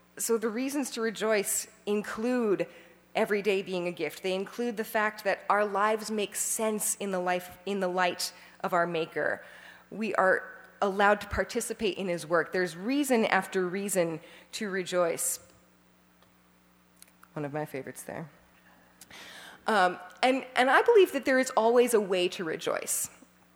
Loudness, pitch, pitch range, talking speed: -29 LUFS, 190 Hz, 170-220 Hz, 155 wpm